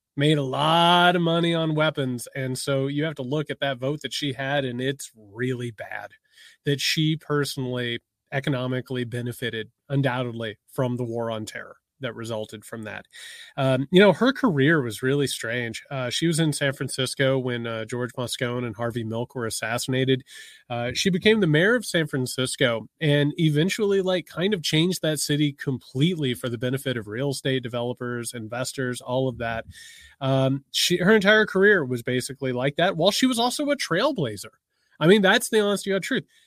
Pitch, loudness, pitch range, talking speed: 135 Hz, -24 LUFS, 125-160 Hz, 185 wpm